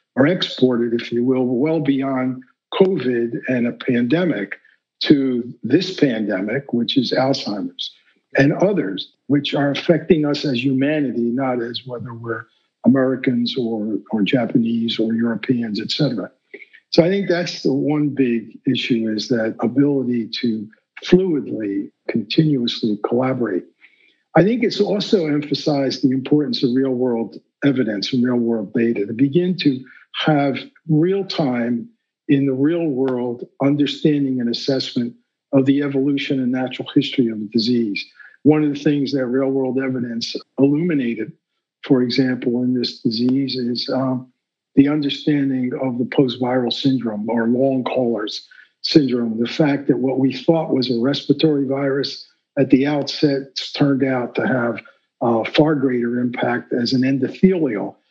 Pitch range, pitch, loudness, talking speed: 120-145 Hz, 130 Hz, -19 LUFS, 145 wpm